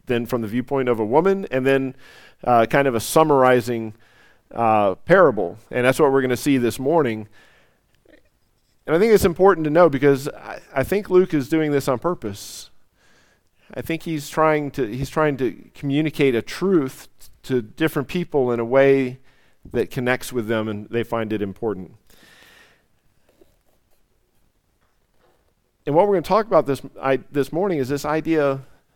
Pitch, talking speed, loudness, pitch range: 135 Hz, 170 wpm, -20 LUFS, 120-155 Hz